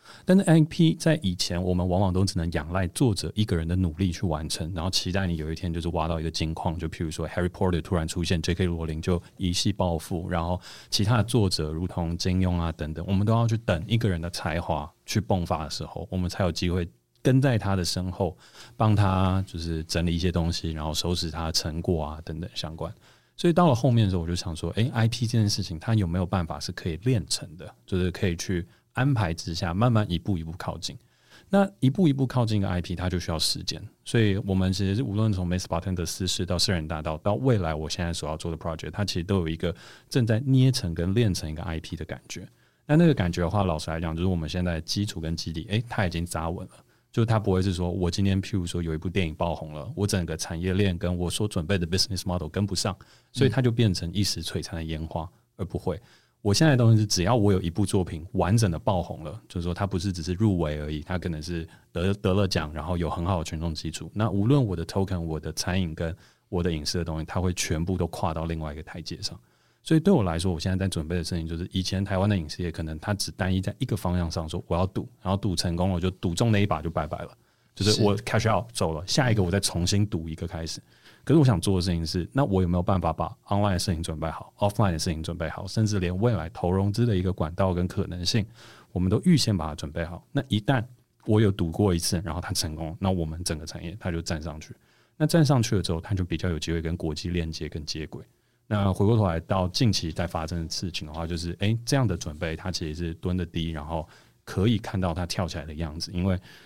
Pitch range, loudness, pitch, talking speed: 85-105 Hz, -27 LUFS, 90 Hz, 390 characters per minute